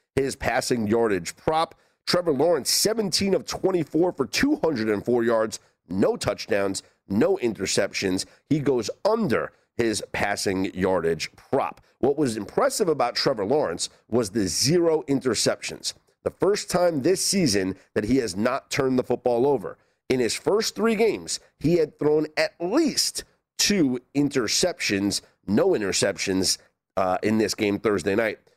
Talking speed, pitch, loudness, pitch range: 140 wpm, 130 Hz, -24 LUFS, 105-175 Hz